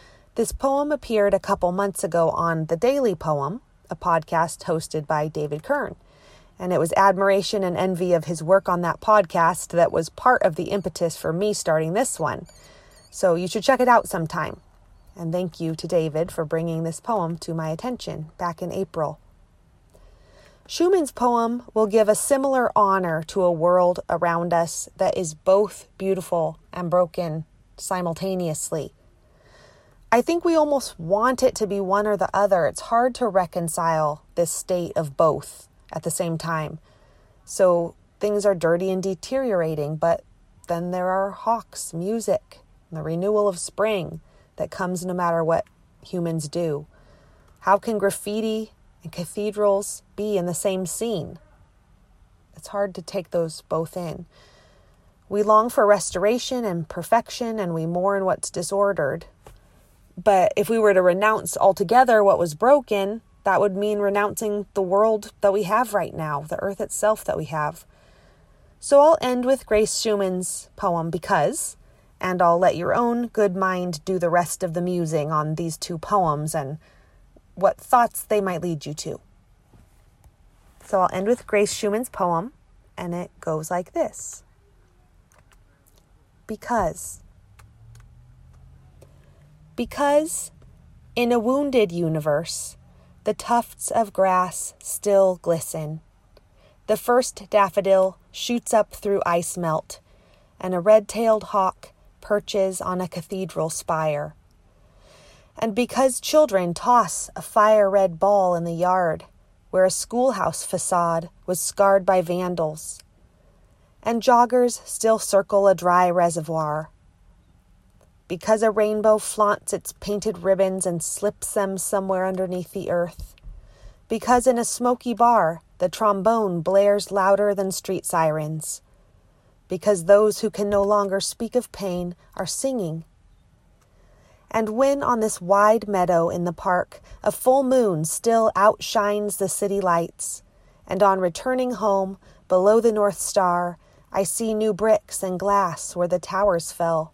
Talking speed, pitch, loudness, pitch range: 145 wpm, 190 Hz, -22 LUFS, 165-210 Hz